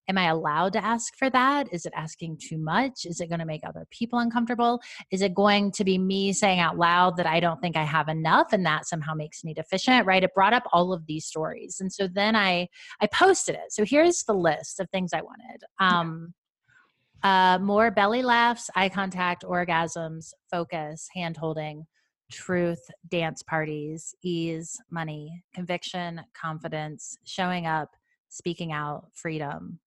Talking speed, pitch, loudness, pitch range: 175 wpm, 180 Hz, -25 LUFS, 160-200 Hz